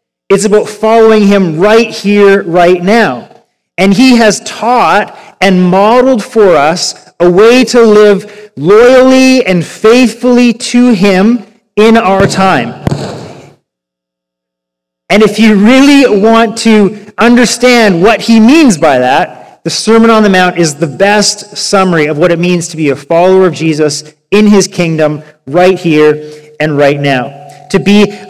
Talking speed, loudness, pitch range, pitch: 145 wpm, -6 LUFS, 170-225 Hz, 200 Hz